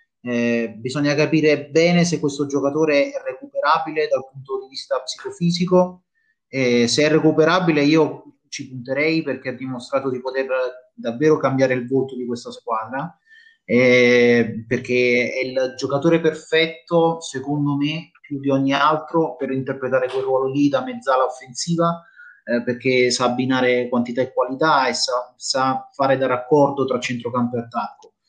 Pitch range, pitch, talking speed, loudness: 125-160 Hz, 135 Hz, 150 wpm, -20 LUFS